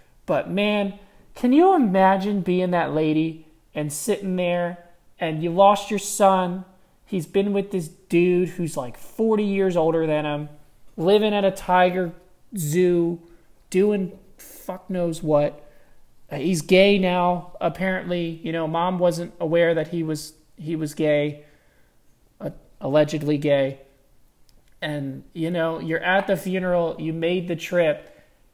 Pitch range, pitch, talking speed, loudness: 160-190 Hz, 175 Hz, 135 wpm, -22 LUFS